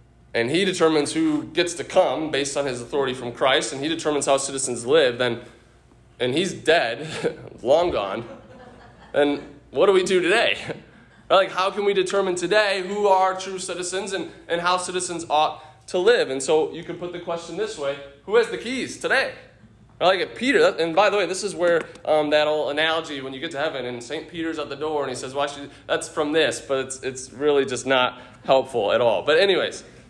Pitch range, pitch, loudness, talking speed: 140-185 Hz, 160 Hz, -22 LUFS, 210 wpm